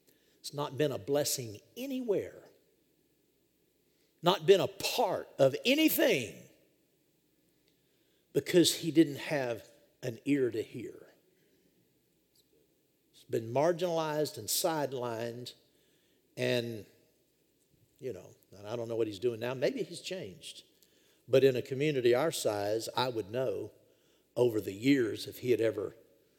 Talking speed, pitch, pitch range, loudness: 125 wpm, 140 Hz, 120-170 Hz, -31 LUFS